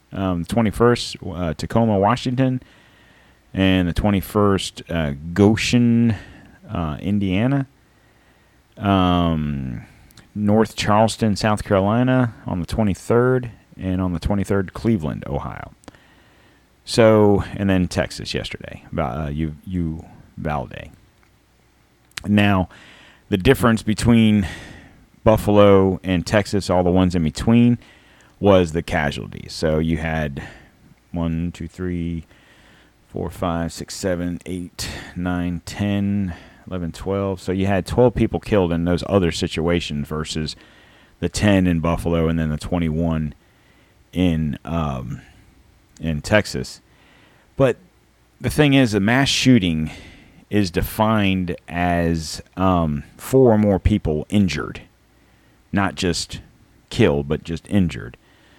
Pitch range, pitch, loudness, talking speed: 85-105 Hz, 95 Hz, -20 LUFS, 115 wpm